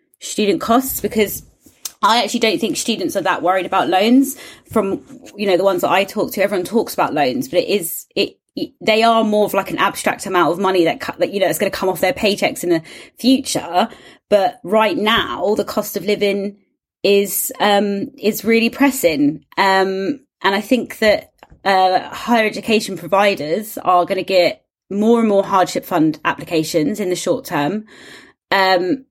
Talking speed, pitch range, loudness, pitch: 190 wpm, 190-230 Hz, -17 LUFS, 205 Hz